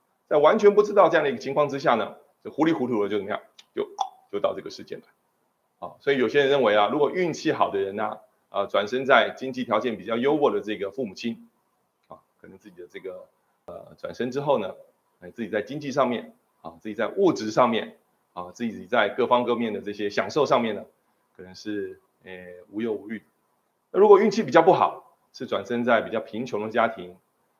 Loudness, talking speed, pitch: -24 LUFS, 310 characters per minute, 120 Hz